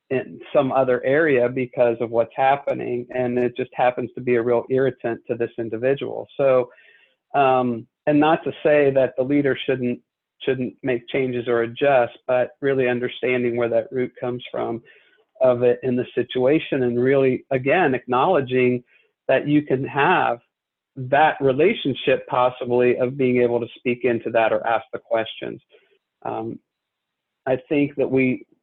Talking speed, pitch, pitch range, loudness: 155 wpm, 125 Hz, 120-135 Hz, -21 LUFS